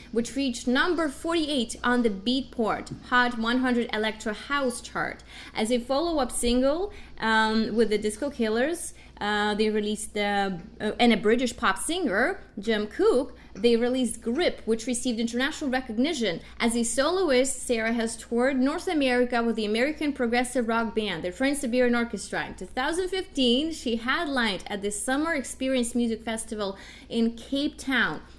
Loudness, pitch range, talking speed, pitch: -26 LUFS, 220-265 Hz, 150 wpm, 245 Hz